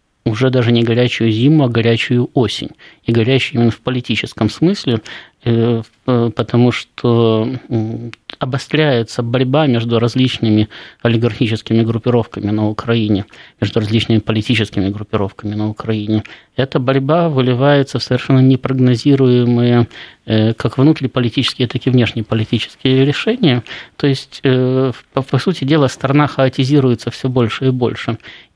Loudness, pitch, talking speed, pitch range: -15 LUFS, 120 Hz, 110 wpm, 115-130 Hz